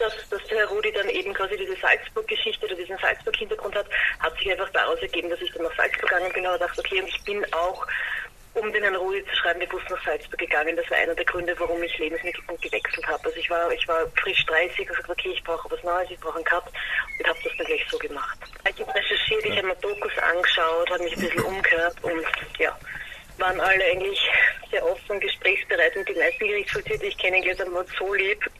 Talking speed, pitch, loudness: 230 wpm, 220 Hz, -24 LUFS